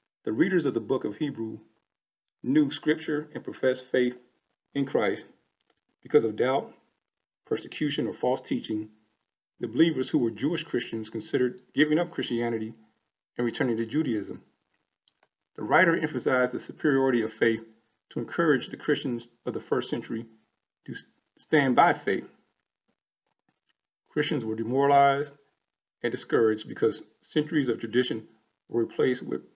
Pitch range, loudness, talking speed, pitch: 115-145 Hz, -27 LUFS, 135 wpm, 125 Hz